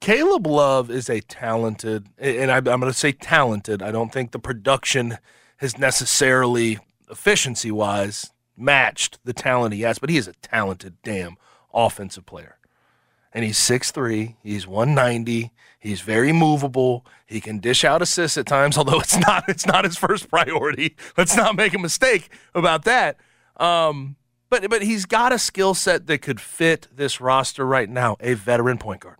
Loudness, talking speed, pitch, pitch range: -20 LUFS, 165 wpm, 130 Hz, 115-155 Hz